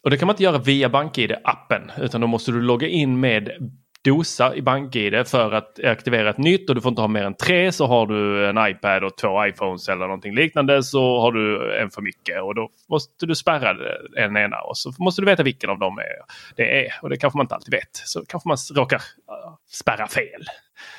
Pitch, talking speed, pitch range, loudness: 130 Hz, 225 wpm, 115-155 Hz, -20 LUFS